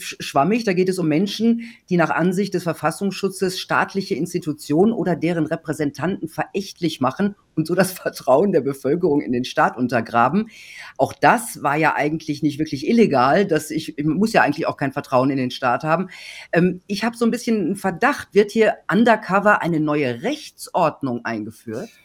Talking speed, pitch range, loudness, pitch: 175 wpm, 150-200 Hz, -20 LUFS, 165 Hz